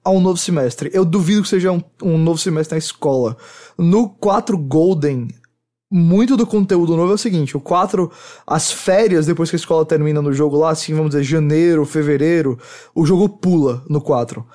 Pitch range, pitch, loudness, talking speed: 150-185 Hz, 165 Hz, -16 LUFS, 190 wpm